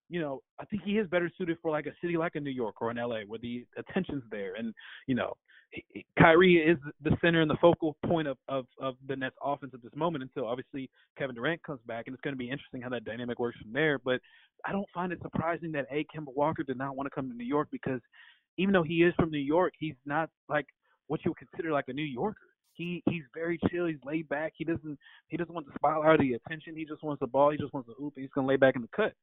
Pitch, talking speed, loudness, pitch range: 150 Hz, 275 wpm, -31 LUFS, 135-165 Hz